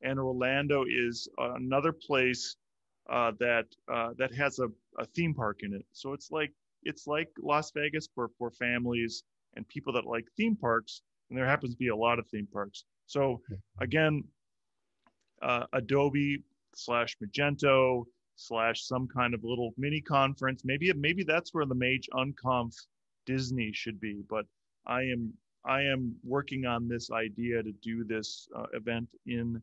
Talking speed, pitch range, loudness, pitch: 160 wpm, 115-140 Hz, -32 LUFS, 125 Hz